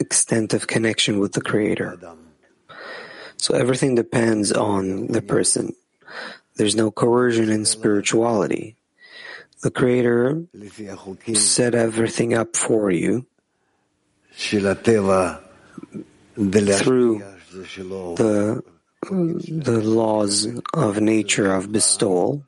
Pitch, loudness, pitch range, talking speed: 110 Hz, -20 LUFS, 100-125 Hz, 85 wpm